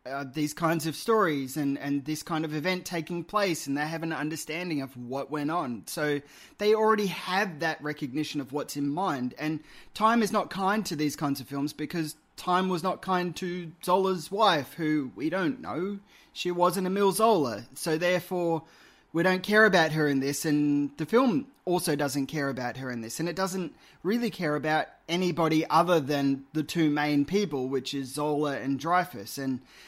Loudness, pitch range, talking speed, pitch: -28 LUFS, 145-185 Hz, 195 wpm, 160 Hz